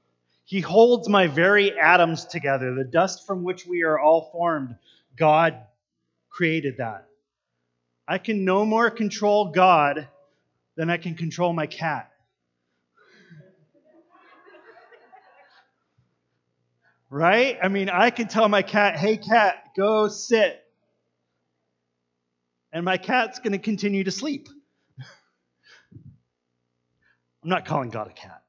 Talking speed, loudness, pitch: 115 wpm, -22 LUFS, 165 Hz